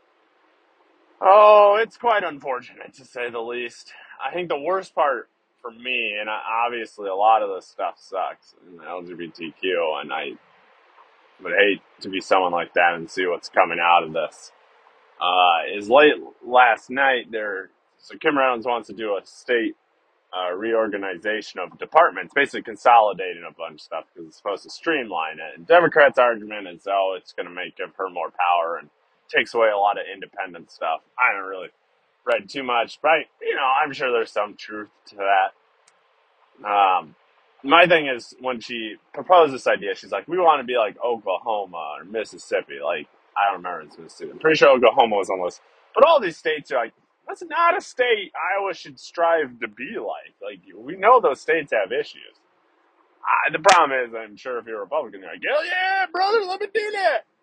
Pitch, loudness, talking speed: 225 Hz, -21 LUFS, 190 wpm